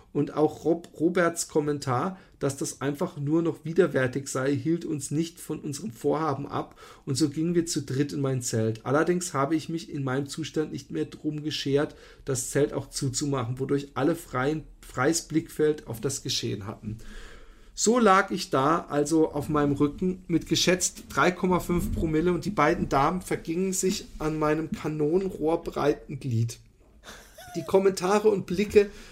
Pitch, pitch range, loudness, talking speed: 155 Hz, 140-170 Hz, -27 LUFS, 160 wpm